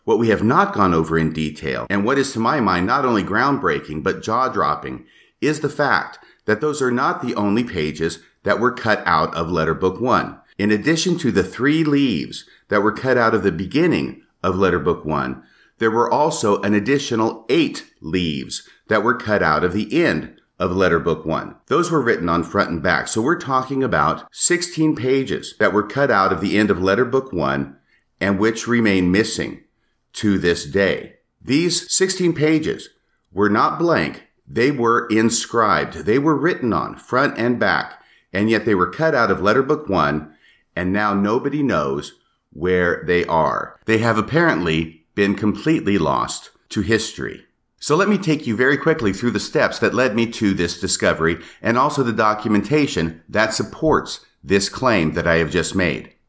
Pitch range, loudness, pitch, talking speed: 85-130 Hz, -19 LUFS, 105 Hz, 185 wpm